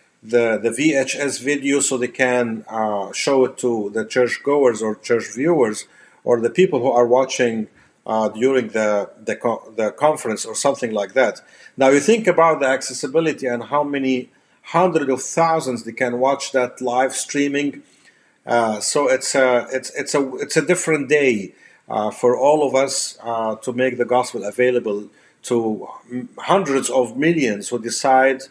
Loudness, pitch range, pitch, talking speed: -19 LUFS, 120-140 Hz, 130 Hz, 170 wpm